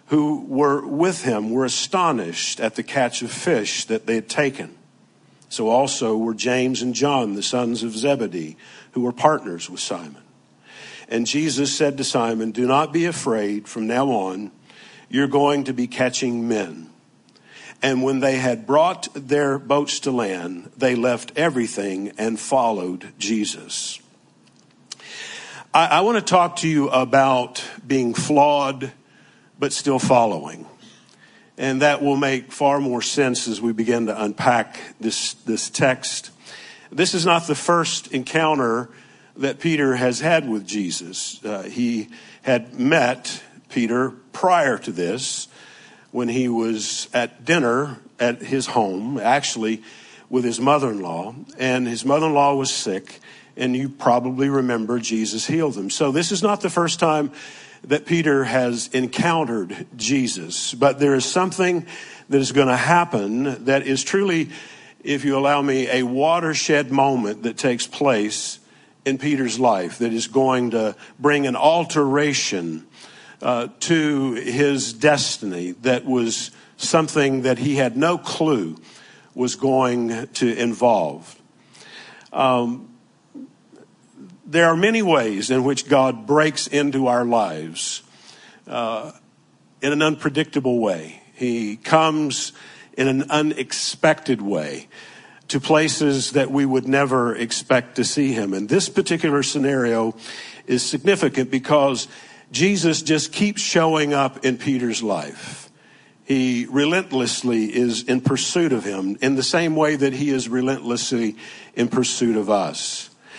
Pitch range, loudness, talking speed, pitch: 120-145 Hz, -20 LUFS, 140 wpm, 135 Hz